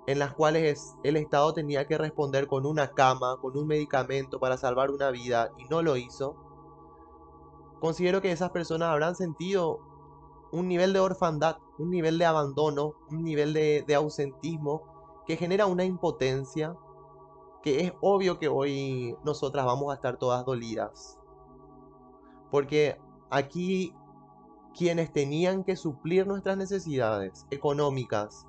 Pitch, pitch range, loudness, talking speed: 150 Hz, 140-165 Hz, -29 LUFS, 135 wpm